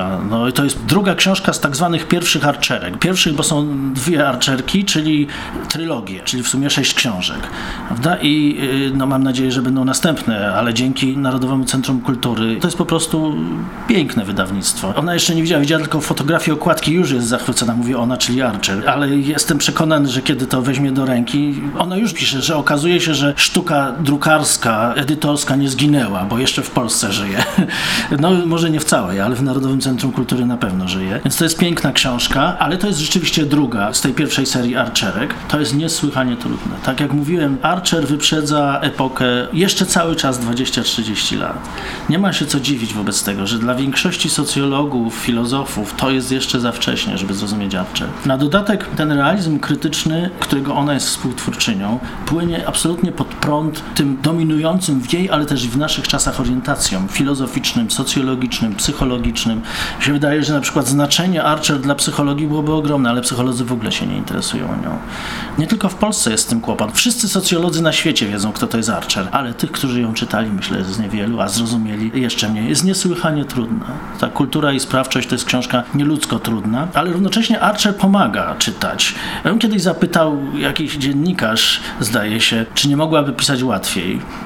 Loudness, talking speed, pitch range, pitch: -16 LUFS, 180 wpm, 125-160 Hz, 140 Hz